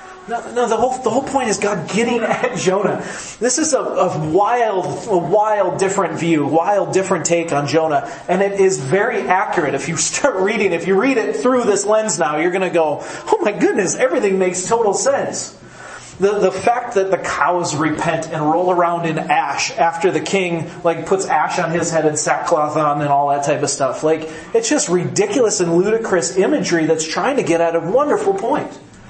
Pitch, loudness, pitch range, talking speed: 180 Hz, -17 LUFS, 165-205 Hz, 200 wpm